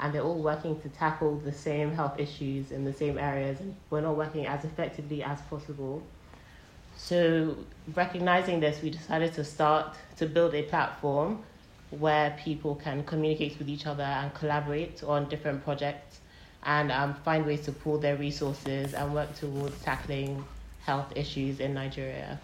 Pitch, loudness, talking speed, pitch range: 150 Hz, -31 LUFS, 160 wpm, 145-155 Hz